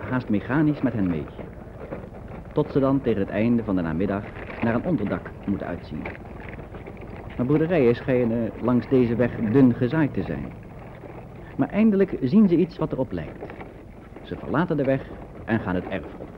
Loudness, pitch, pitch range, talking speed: -23 LUFS, 120 Hz, 100-135 Hz, 170 wpm